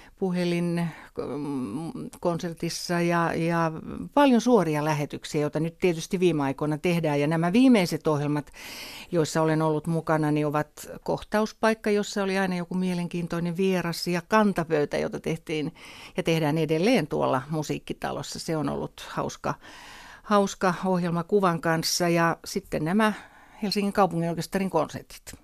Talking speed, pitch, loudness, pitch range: 125 wpm, 170 Hz, -26 LUFS, 160-195 Hz